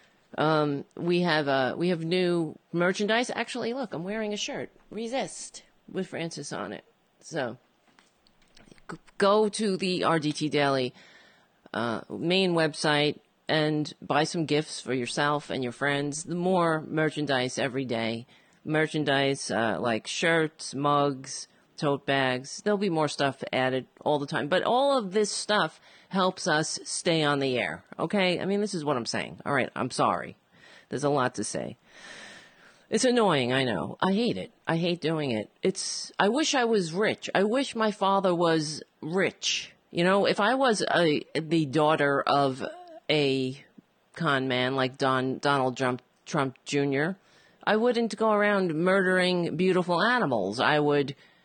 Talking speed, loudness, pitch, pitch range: 155 wpm, -27 LUFS, 160 Hz, 140-195 Hz